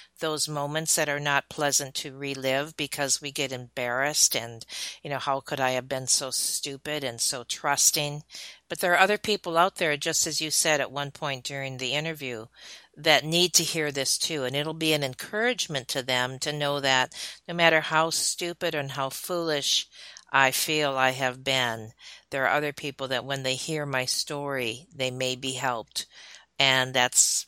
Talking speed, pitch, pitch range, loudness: 190 wpm, 145 Hz, 130-155 Hz, -25 LUFS